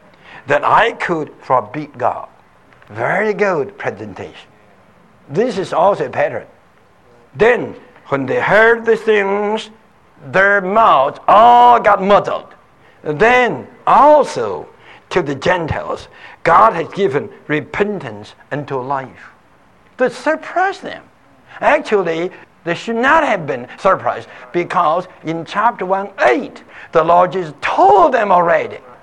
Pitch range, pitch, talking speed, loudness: 165-235 Hz, 200 Hz, 115 wpm, -14 LUFS